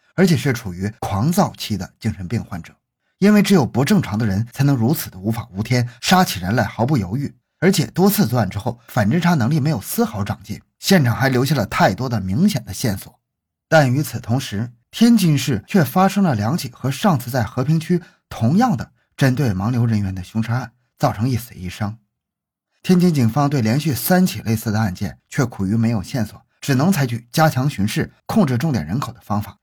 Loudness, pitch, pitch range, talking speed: -19 LUFS, 125 Hz, 110-155 Hz, 305 characters per minute